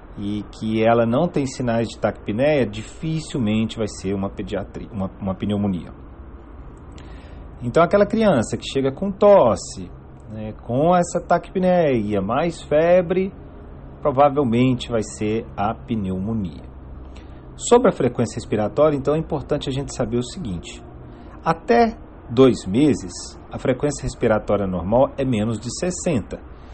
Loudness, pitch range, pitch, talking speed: -20 LUFS, 95-145 Hz, 115 Hz, 125 wpm